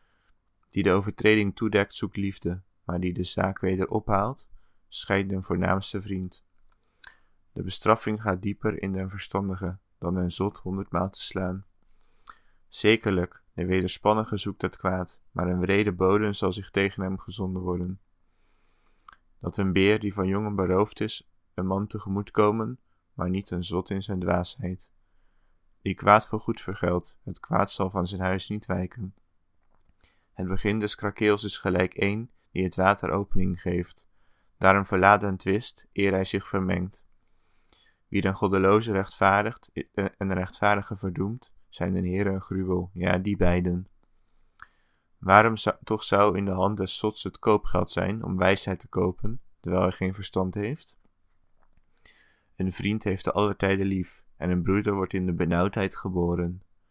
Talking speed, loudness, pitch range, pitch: 155 wpm, -27 LUFS, 90-100 Hz, 95 Hz